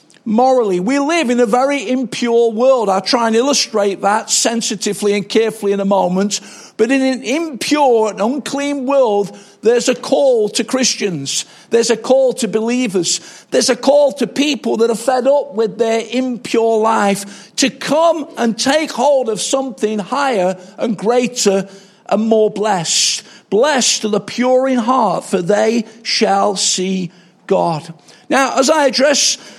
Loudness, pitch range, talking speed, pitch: -15 LUFS, 205-260 Hz, 155 wpm, 230 Hz